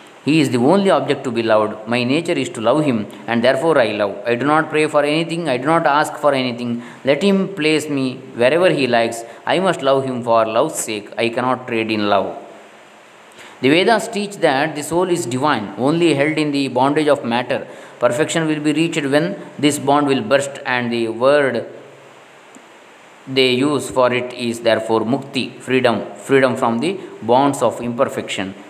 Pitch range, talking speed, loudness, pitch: 120-150 Hz, 190 wpm, -17 LUFS, 135 Hz